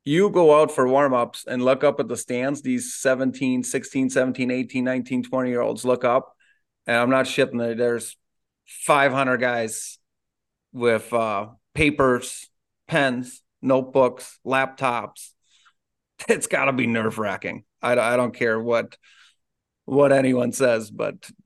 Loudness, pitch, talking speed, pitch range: -22 LUFS, 125 Hz, 145 wpm, 120-135 Hz